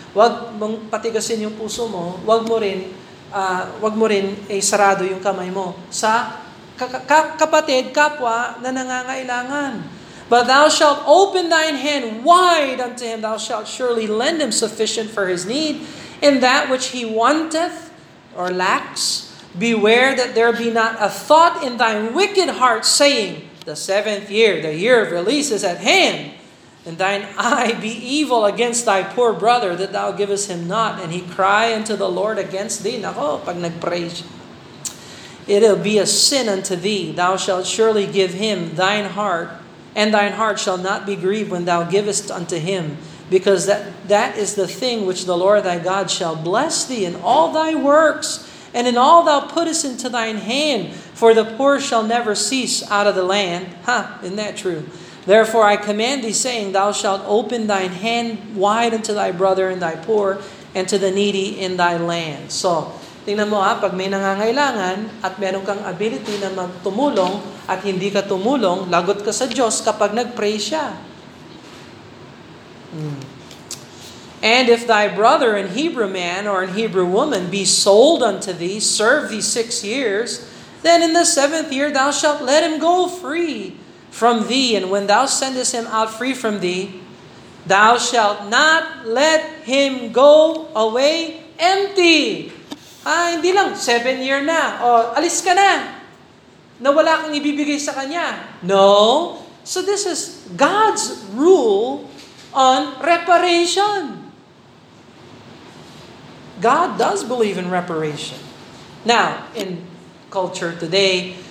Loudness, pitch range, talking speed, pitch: -17 LUFS, 195-270 Hz, 155 wpm, 220 Hz